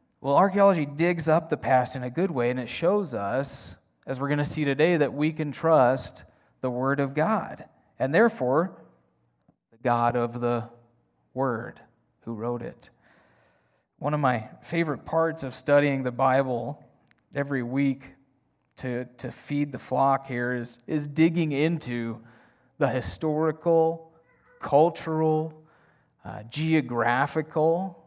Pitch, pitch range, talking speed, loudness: 135 Hz, 120-160 Hz, 135 wpm, -26 LUFS